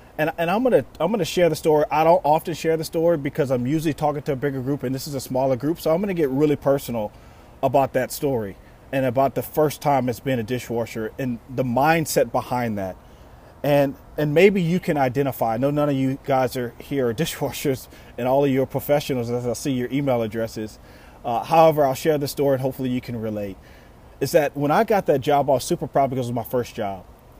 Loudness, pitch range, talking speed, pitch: -22 LUFS, 125-150 Hz, 235 wpm, 135 Hz